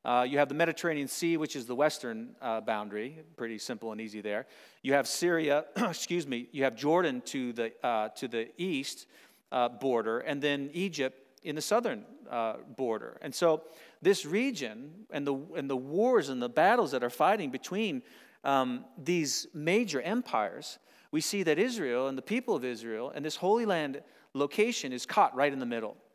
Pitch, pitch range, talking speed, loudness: 150 Hz, 130-175 Hz, 185 wpm, -31 LUFS